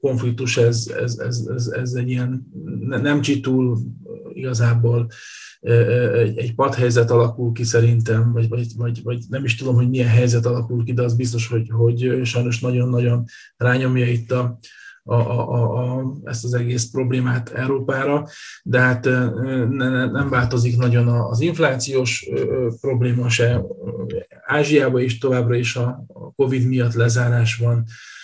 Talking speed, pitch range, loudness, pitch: 135 wpm, 120-130 Hz, -19 LUFS, 120 Hz